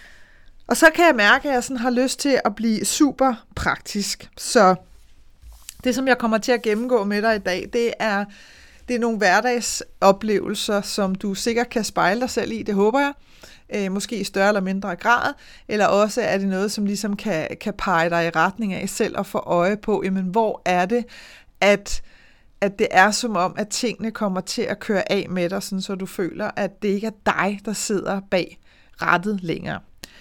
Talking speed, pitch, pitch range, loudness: 205 wpm, 205 Hz, 195-235 Hz, -21 LUFS